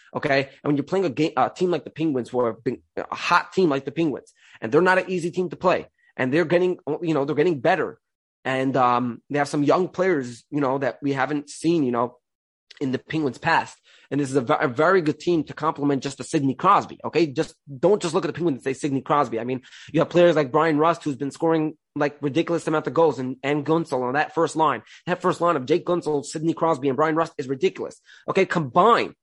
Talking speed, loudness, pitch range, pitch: 245 wpm, -23 LUFS, 140-165 Hz, 150 Hz